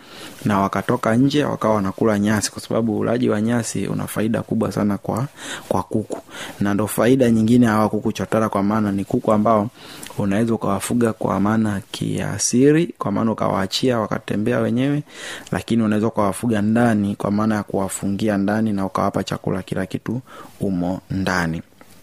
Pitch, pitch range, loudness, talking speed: 110 Hz, 100-115 Hz, -20 LUFS, 155 wpm